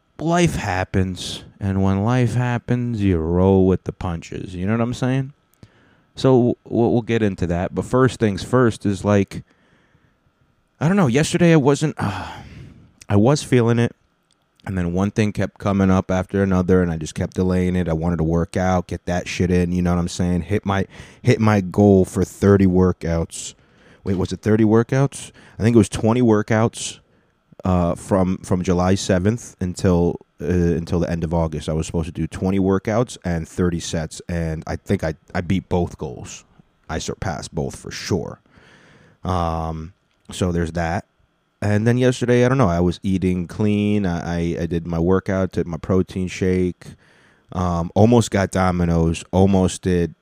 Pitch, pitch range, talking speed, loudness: 95 Hz, 90-110 Hz, 180 wpm, -20 LUFS